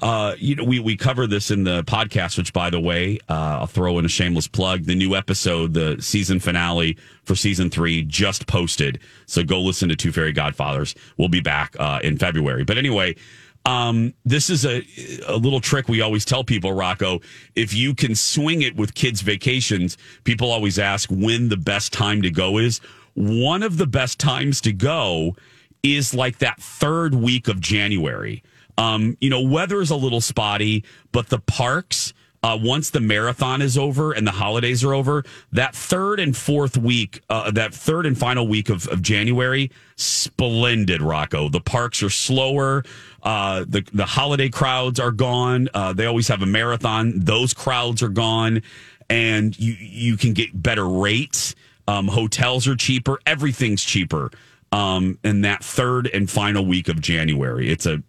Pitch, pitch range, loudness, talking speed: 115 Hz, 100-130 Hz, -20 LUFS, 180 wpm